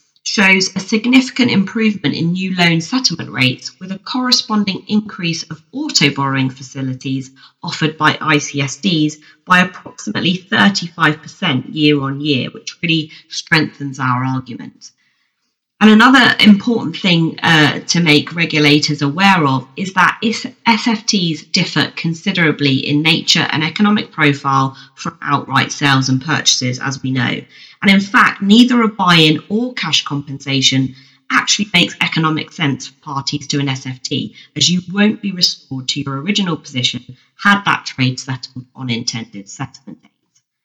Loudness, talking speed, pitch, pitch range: -14 LUFS, 135 wpm, 155 Hz, 135-195 Hz